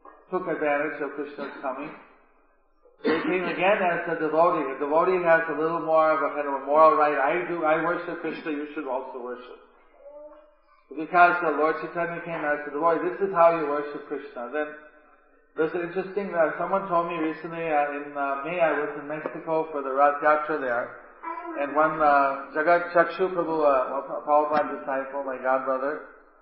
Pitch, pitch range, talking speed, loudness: 155 Hz, 145-170 Hz, 180 wpm, -25 LUFS